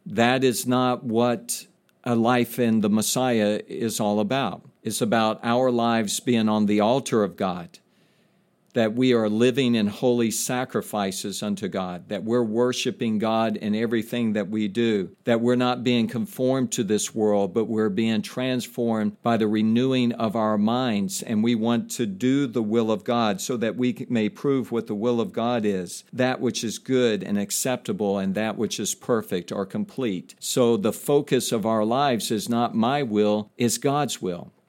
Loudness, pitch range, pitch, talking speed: -24 LUFS, 110-125 Hz, 115 Hz, 180 wpm